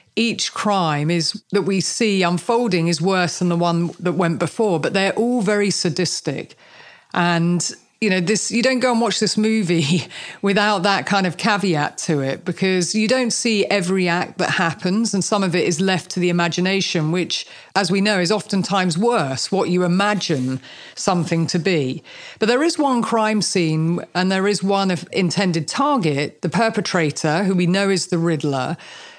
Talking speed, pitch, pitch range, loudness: 185 wpm, 185 Hz, 170-210 Hz, -19 LUFS